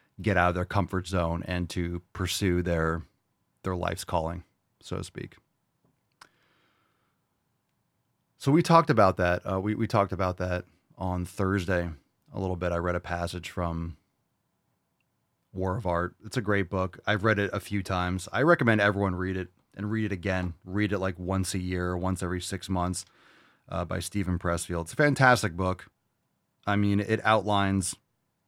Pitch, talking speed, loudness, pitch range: 95 Hz, 170 wpm, -28 LUFS, 90-100 Hz